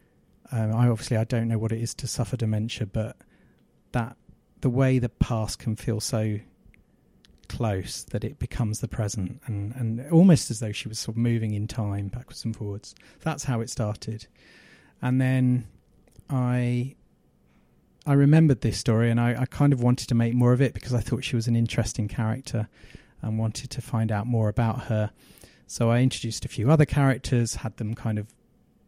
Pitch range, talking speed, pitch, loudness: 110-125 Hz, 190 wpm, 115 Hz, -26 LUFS